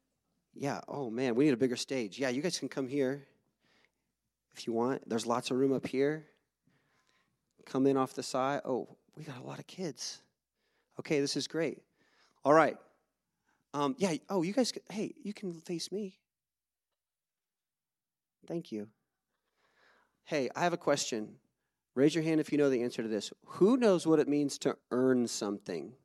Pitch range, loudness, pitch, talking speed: 125-160 Hz, -32 LUFS, 140 Hz, 175 wpm